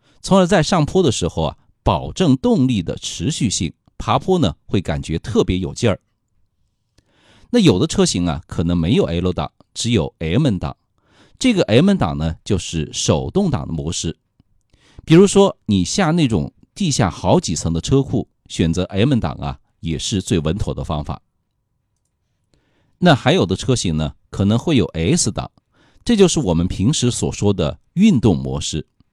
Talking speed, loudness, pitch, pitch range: 230 characters per minute, -18 LUFS, 100 Hz, 85-135 Hz